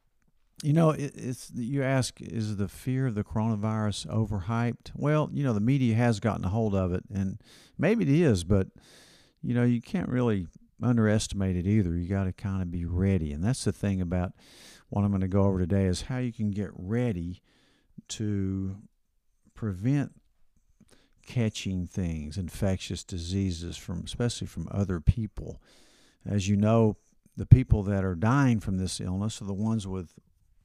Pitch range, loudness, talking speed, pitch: 95-115 Hz, -28 LUFS, 170 wpm, 105 Hz